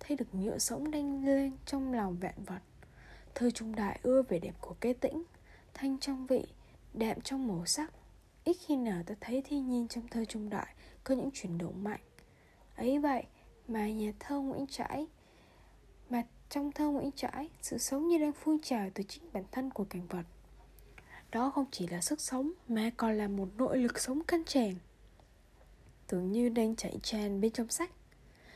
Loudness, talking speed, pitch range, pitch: -35 LUFS, 185 wpm, 205-275 Hz, 240 Hz